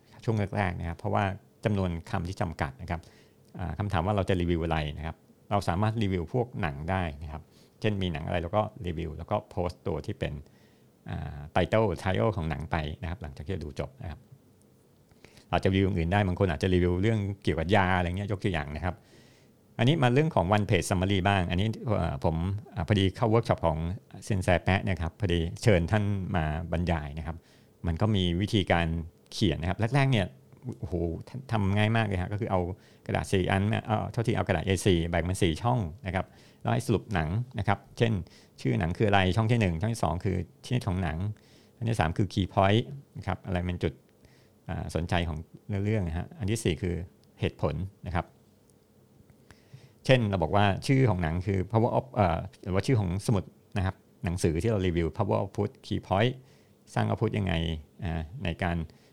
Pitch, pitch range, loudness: 95 Hz, 85-110 Hz, -29 LUFS